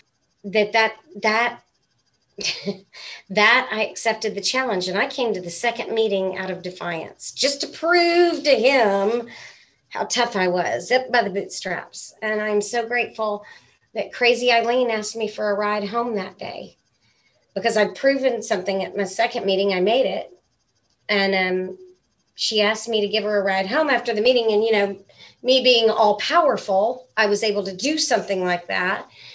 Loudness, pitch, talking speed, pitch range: -21 LUFS, 215 Hz, 175 wpm, 200-240 Hz